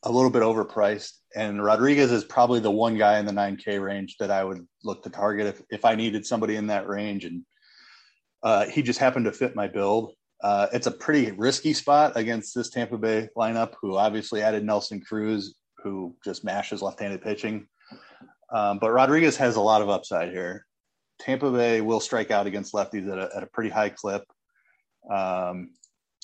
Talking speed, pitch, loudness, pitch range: 190 wpm, 110 Hz, -25 LUFS, 100-115 Hz